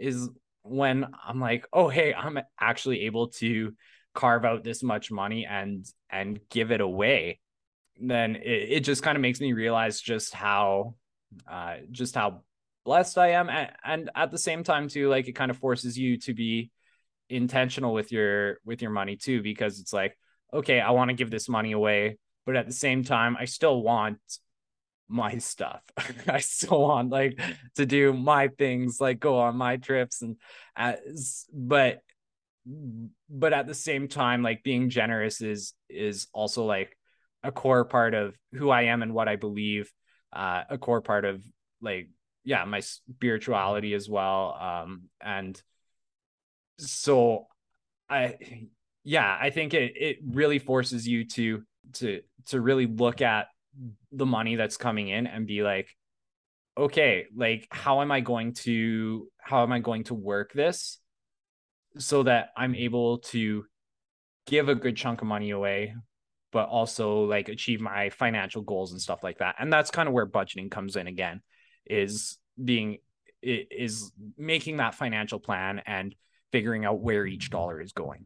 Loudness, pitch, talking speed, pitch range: -27 LUFS, 120 Hz, 170 wpm, 105-130 Hz